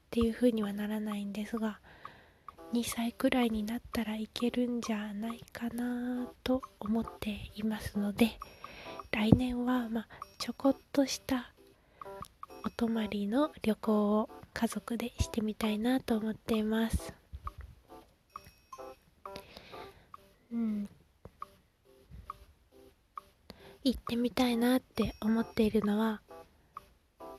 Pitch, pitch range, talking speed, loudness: 230 Hz, 215-240 Hz, 215 characters per minute, -33 LUFS